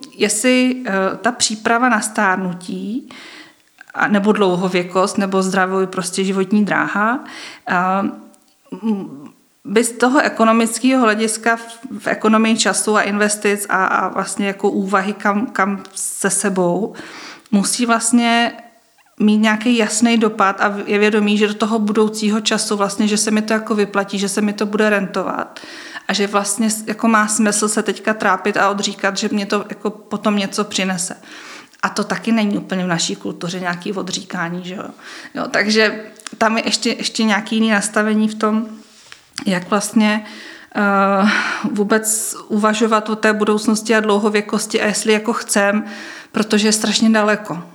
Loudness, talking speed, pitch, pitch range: -17 LUFS, 145 wpm, 215 Hz, 200-225 Hz